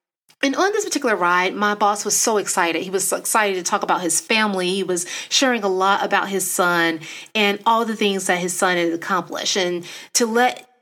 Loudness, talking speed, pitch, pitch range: -19 LUFS, 215 wpm, 200 Hz, 180-225 Hz